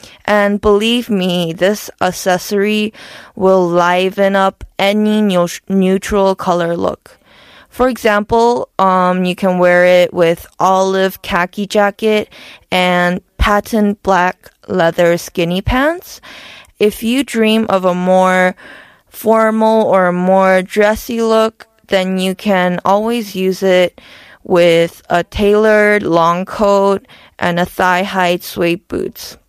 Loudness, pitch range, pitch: -13 LUFS, 180-210 Hz, 190 Hz